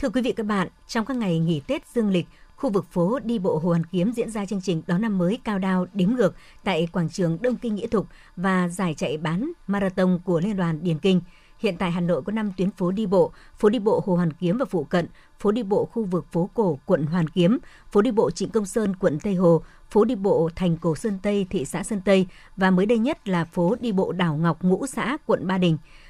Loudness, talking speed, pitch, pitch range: -24 LUFS, 260 wpm, 190 Hz, 175-215 Hz